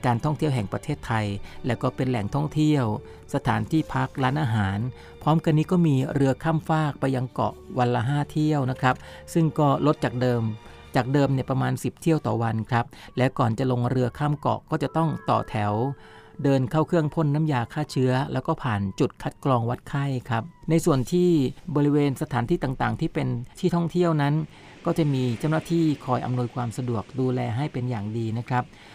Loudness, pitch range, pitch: -25 LUFS, 120-150 Hz, 130 Hz